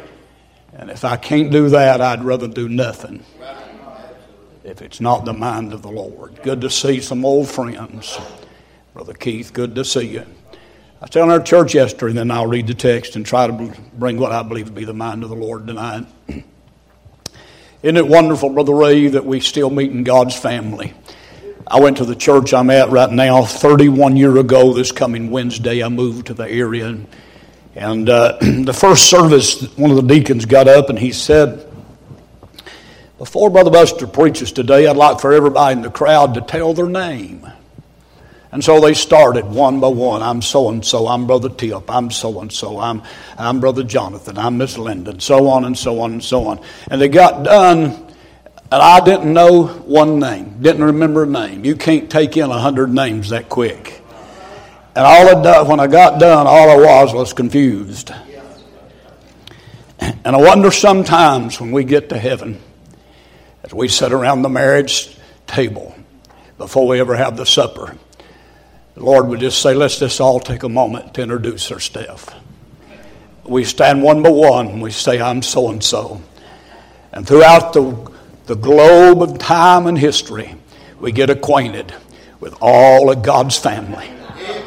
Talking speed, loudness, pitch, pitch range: 180 wpm, -11 LUFS, 130 Hz, 120-145 Hz